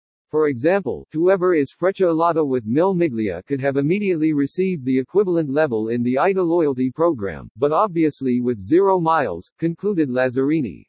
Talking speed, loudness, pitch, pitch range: 150 wpm, -20 LUFS, 155 Hz, 130-175 Hz